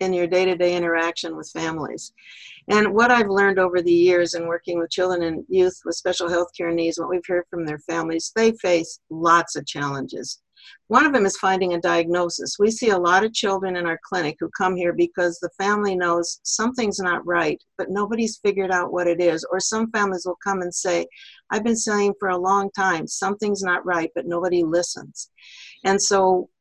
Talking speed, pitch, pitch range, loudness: 205 wpm, 180 Hz, 170-200 Hz, -21 LUFS